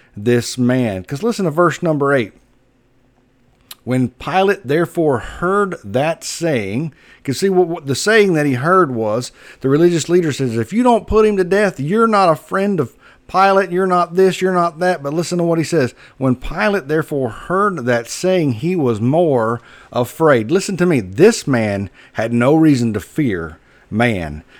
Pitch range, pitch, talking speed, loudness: 125-180 Hz, 155 Hz, 180 wpm, -16 LUFS